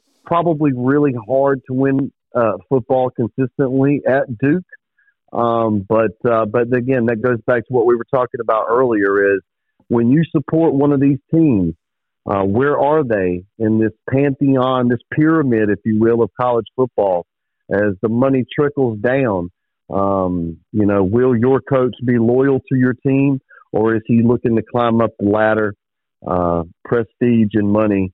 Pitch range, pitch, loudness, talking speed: 110-135 Hz, 120 Hz, -16 LUFS, 165 wpm